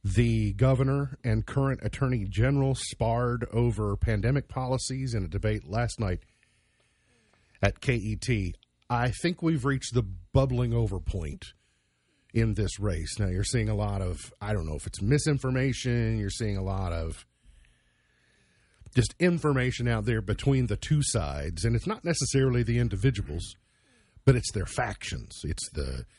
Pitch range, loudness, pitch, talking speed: 100-125 Hz, -29 LUFS, 115 Hz, 150 wpm